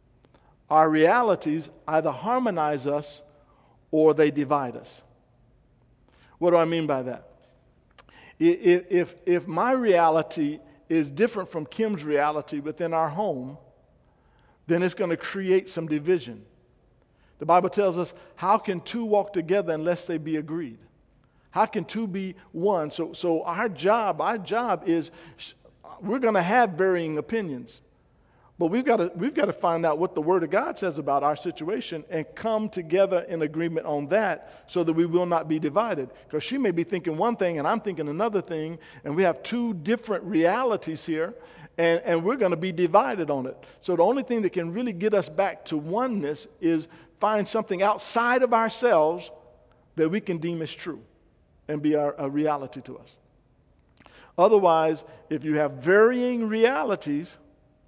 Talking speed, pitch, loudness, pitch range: 170 wpm, 170 Hz, -25 LUFS, 155-200 Hz